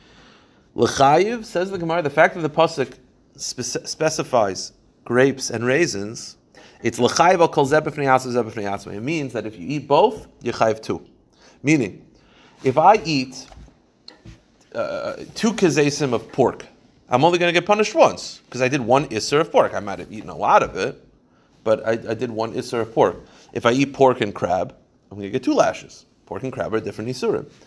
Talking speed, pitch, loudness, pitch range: 185 wpm, 130 Hz, -20 LUFS, 115-155 Hz